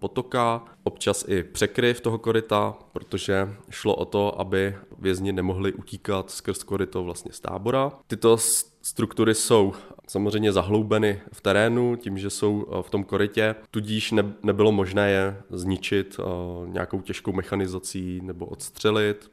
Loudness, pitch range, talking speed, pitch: -25 LUFS, 95-110 Hz, 130 wpm, 100 Hz